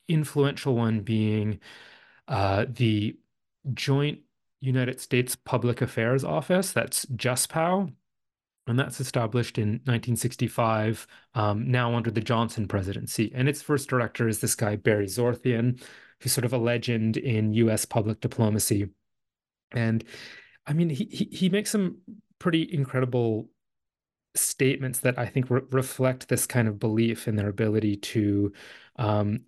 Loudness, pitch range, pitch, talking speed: -26 LUFS, 110-130 Hz, 120 Hz, 140 wpm